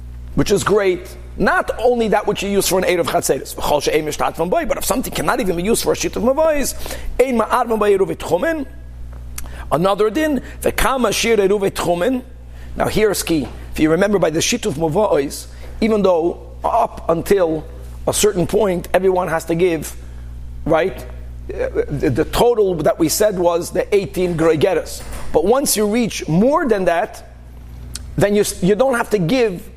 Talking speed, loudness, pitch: 150 wpm, -17 LUFS, 190 Hz